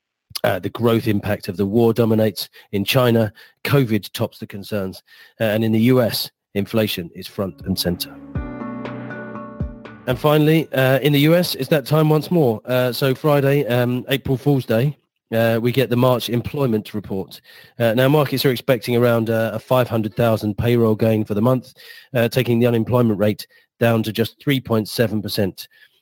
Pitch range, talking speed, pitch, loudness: 105-130 Hz, 165 wpm, 115 Hz, -19 LUFS